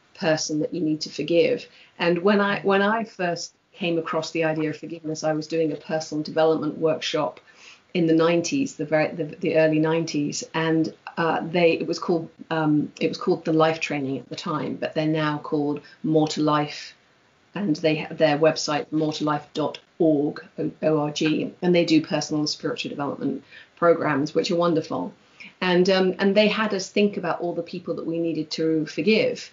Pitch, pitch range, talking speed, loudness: 160 Hz, 155-175 Hz, 190 wpm, -24 LUFS